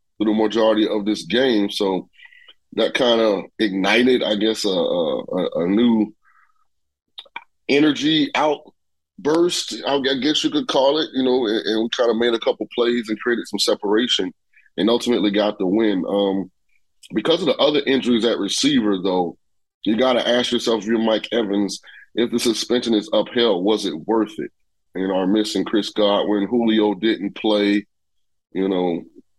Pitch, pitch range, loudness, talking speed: 110 Hz, 105-125 Hz, -19 LUFS, 165 wpm